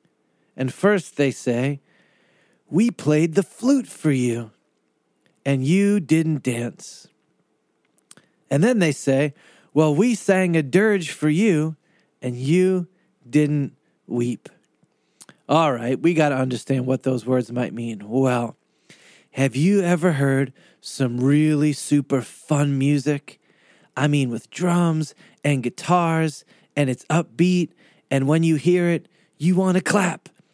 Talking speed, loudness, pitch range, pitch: 135 wpm, -21 LUFS, 130-175 Hz, 150 Hz